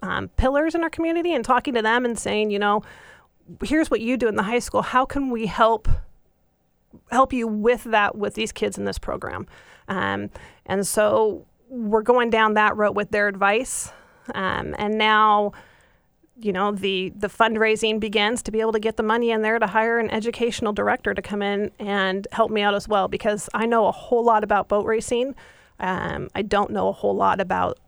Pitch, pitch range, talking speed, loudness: 220 Hz, 205-235 Hz, 205 wpm, -22 LUFS